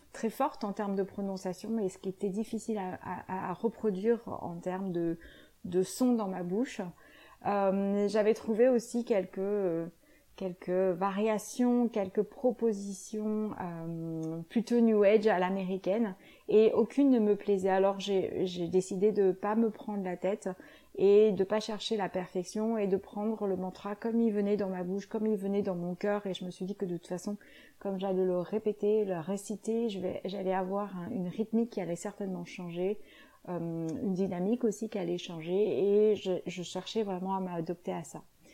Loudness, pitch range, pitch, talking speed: -32 LUFS, 185-215 Hz, 200 Hz, 185 wpm